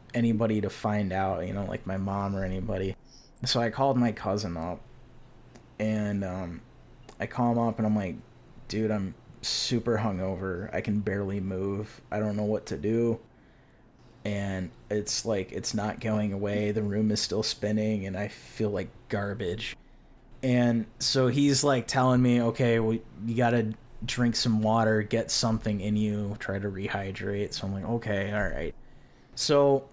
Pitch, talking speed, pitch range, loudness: 110 Hz, 170 wpm, 100-120 Hz, -29 LUFS